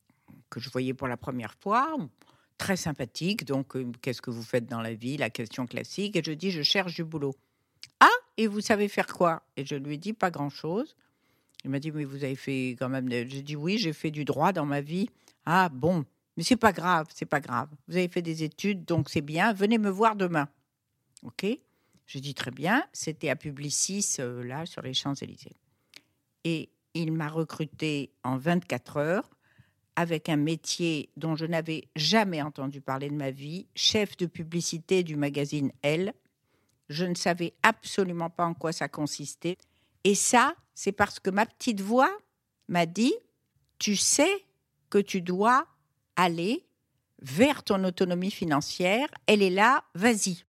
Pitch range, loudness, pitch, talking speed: 140-195 Hz, -28 LUFS, 160 Hz, 180 wpm